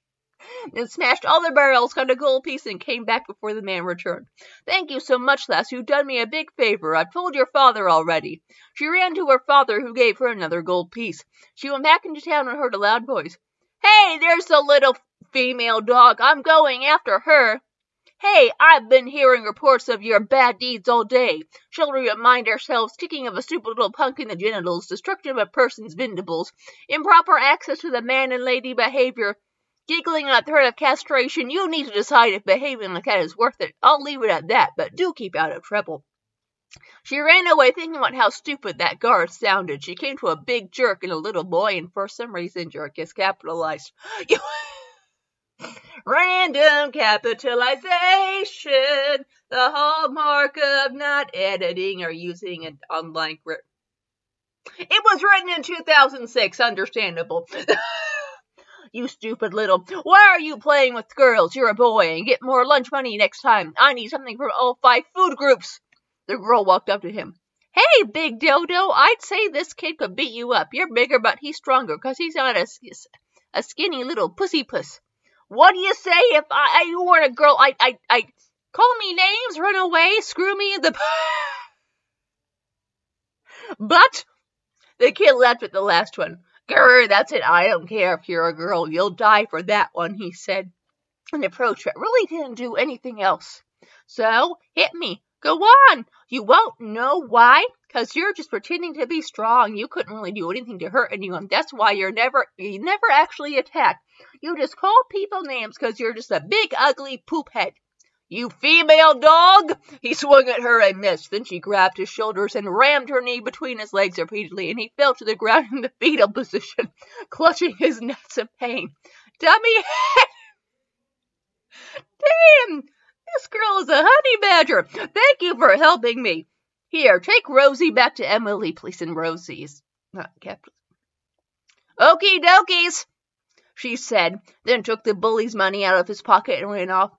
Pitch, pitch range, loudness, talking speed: 270 Hz, 220-330 Hz, -18 LUFS, 180 wpm